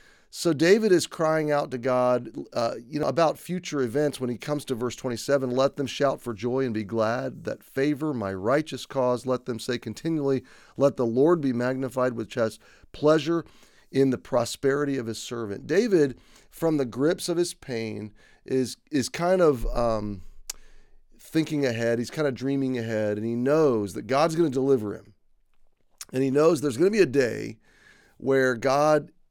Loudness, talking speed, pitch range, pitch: -25 LUFS, 180 wpm, 120-150 Hz, 130 Hz